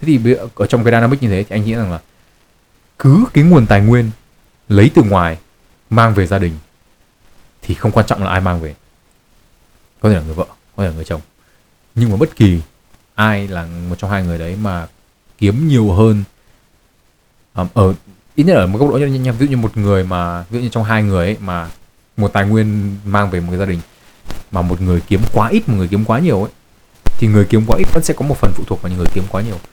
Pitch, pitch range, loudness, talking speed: 100 Hz, 90-115 Hz, -14 LUFS, 240 wpm